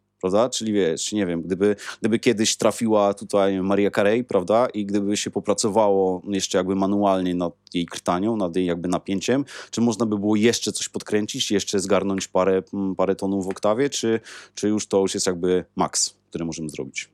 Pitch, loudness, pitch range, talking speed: 100 Hz, -22 LUFS, 95-105 Hz, 180 wpm